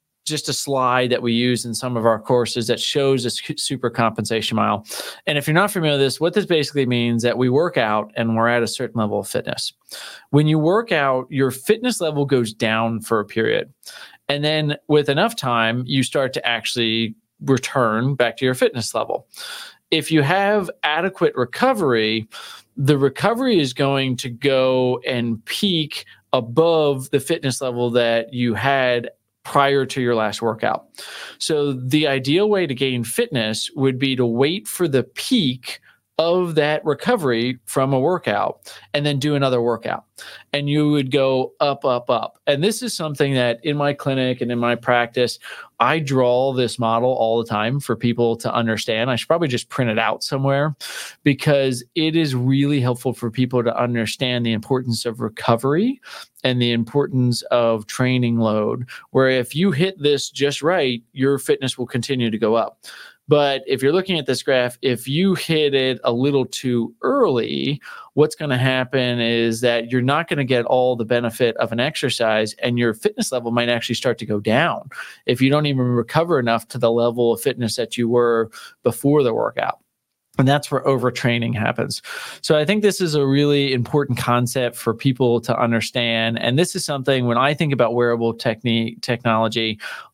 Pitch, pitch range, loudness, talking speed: 130 Hz, 120-145 Hz, -20 LUFS, 185 wpm